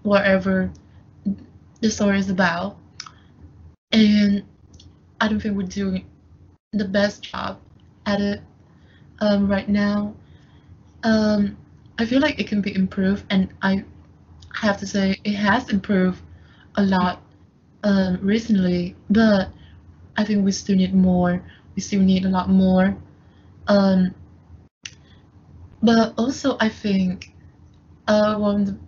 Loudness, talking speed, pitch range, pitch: -21 LUFS, 125 wpm, 185-205 Hz, 195 Hz